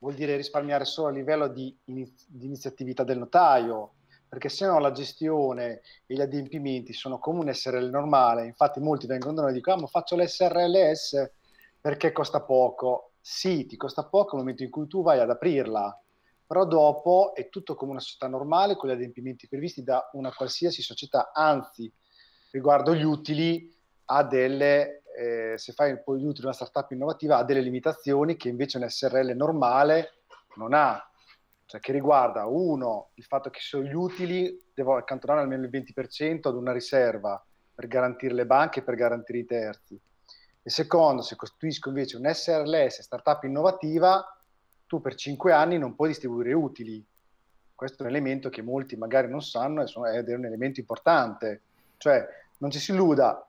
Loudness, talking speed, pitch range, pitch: -26 LUFS, 170 wpm, 125-155 Hz, 135 Hz